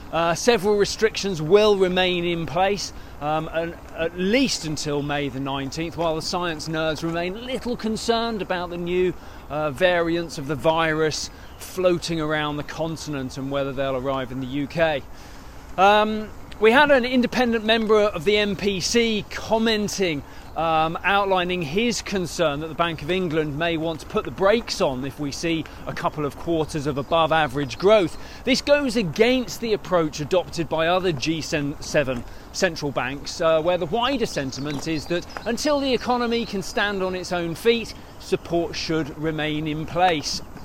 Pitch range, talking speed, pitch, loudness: 155-205 Hz, 165 wpm, 170 Hz, -23 LUFS